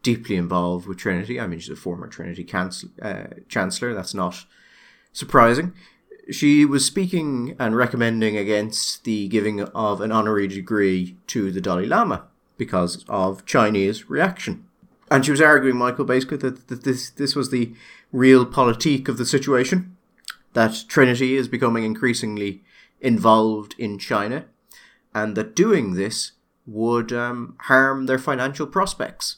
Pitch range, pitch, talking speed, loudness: 105-135 Hz, 120 Hz, 145 wpm, -21 LUFS